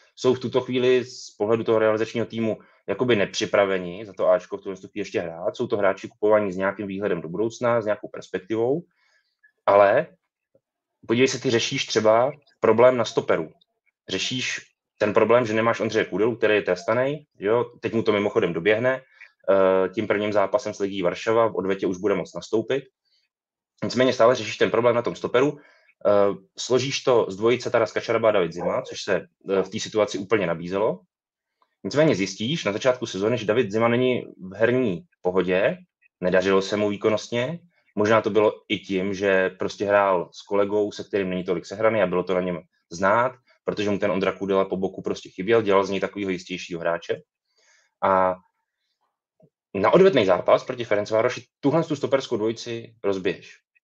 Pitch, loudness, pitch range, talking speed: 105 Hz, -23 LUFS, 95-120 Hz, 175 wpm